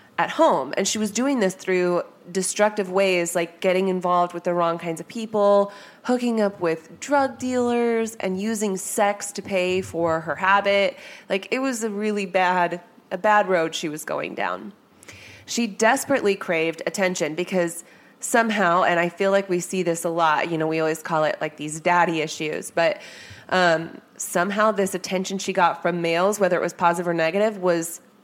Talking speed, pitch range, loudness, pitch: 185 wpm, 170-210 Hz, -22 LUFS, 185 Hz